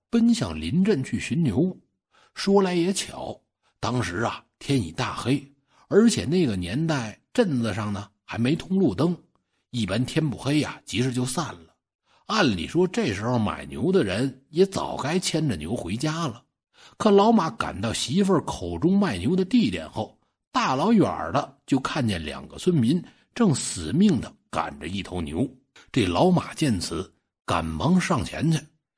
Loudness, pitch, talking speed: -24 LUFS, 135 Hz, 225 characters per minute